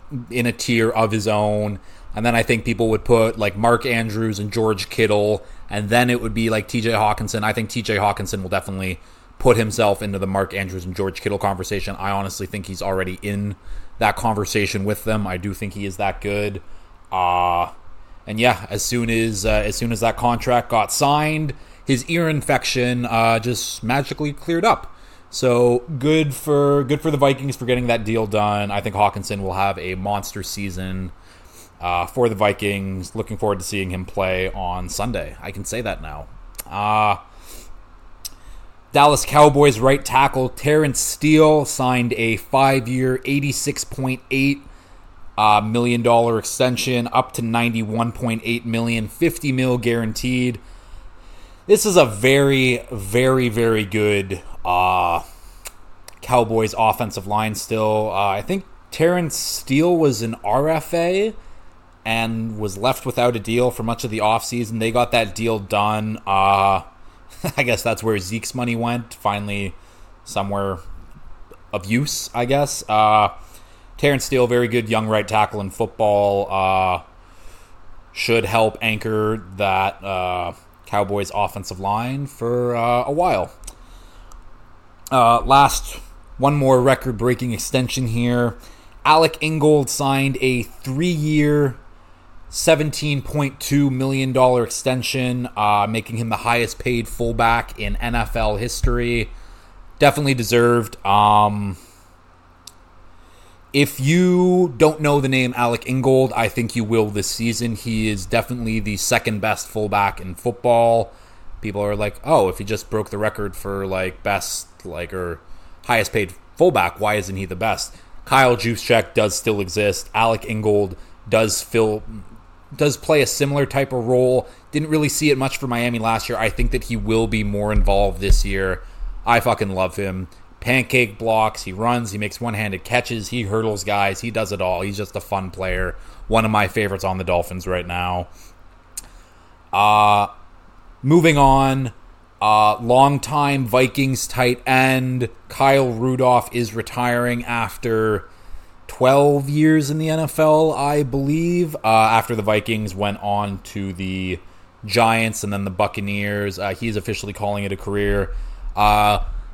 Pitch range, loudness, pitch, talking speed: 95-125 Hz, -19 LUFS, 110 Hz, 150 wpm